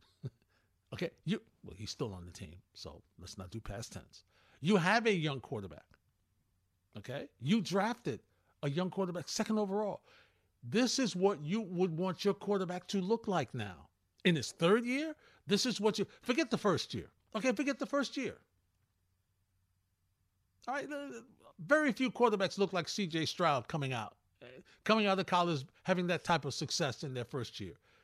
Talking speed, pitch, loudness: 170 wpm, 170 Hz, -35 LUFS